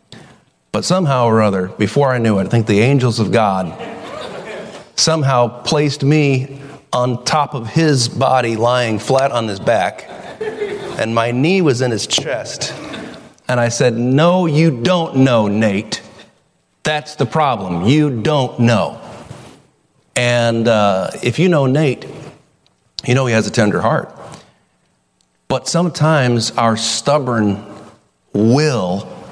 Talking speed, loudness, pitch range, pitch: 135 wpm, -15 LUFS, 110-150 Hz, 125 Hz